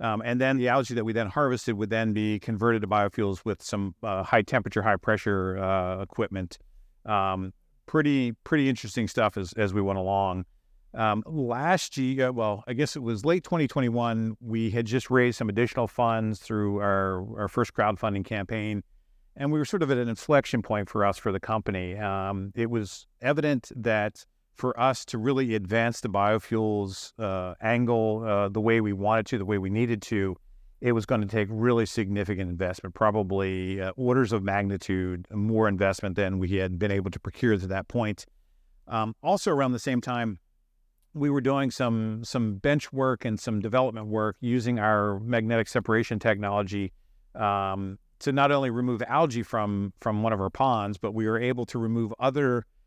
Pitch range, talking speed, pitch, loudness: 100-120 Hz, 185 wpm, 110 Hz, -27 LUFS